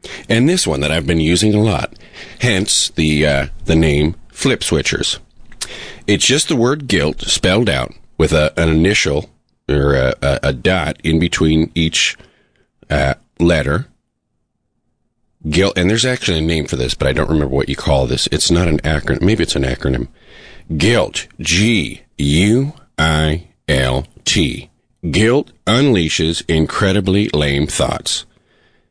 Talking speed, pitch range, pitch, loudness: 150 wpm, 75-95 Hz, 80 Hz, -15 LUFS